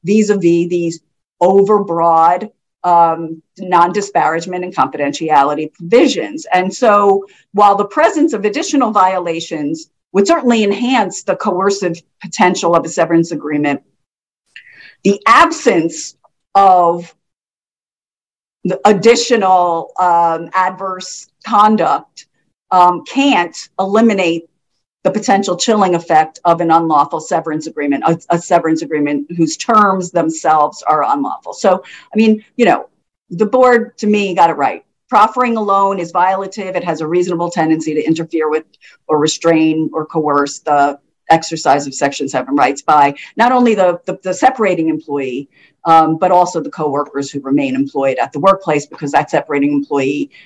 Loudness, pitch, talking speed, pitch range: -13 LUFS, 175 Hz, 135 wpm, 155-200 Hz